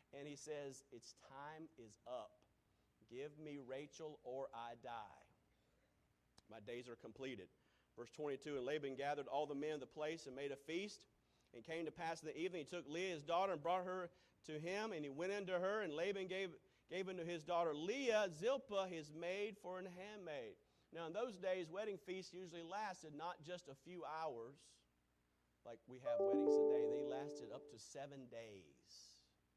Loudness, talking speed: -46 LUFS, 185 wpm